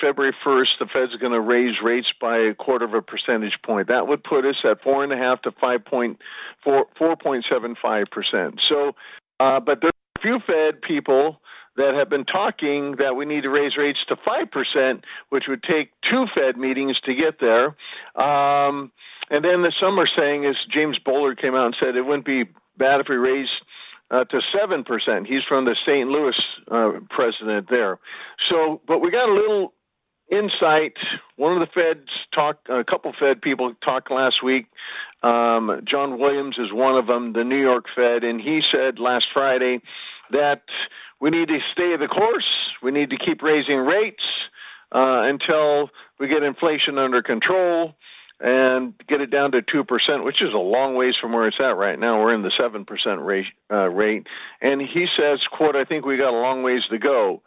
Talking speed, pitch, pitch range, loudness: 185 wpm, 135 Hz, 125-150 Hz, -20 LUFS